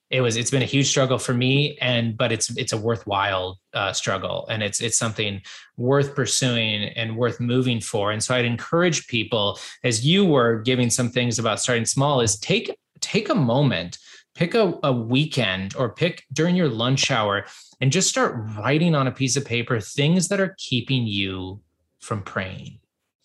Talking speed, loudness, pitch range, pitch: 185 wpm, -22 LUFS, 115-140 Hz, 125 Hz